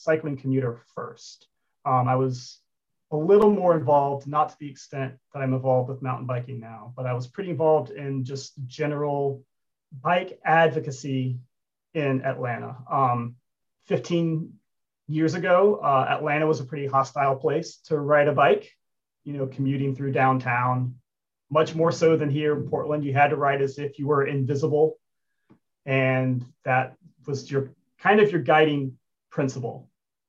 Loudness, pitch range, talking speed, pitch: -24 LUFS, 130-155 Hz, 155 wpm, 140 Hz